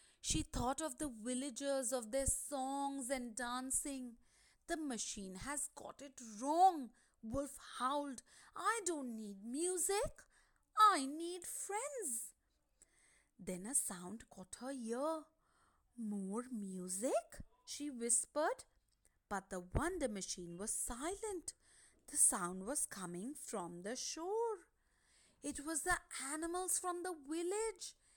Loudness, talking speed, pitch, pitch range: -40 LUFS, 115 wpm, 275 Hz, 235-325 Hz